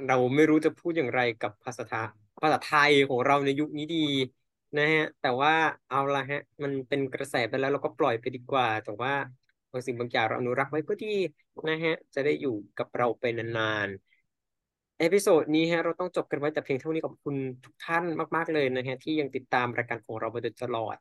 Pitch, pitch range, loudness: 140 Hz, 125-155 Hz, -28 LUFS